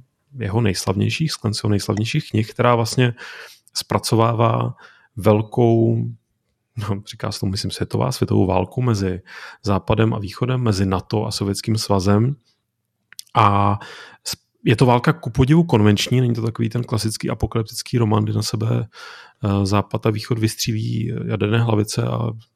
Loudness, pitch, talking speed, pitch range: -20 LUFS, 110 Hz, 135 wpm, 105-120 Hz